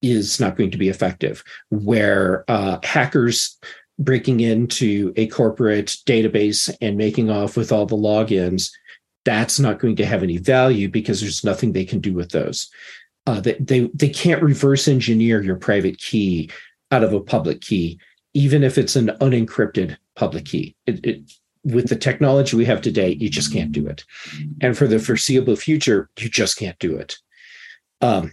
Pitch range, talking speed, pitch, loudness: 105-135 Hz, 175 wpm, 115 Hz, -19 LUFS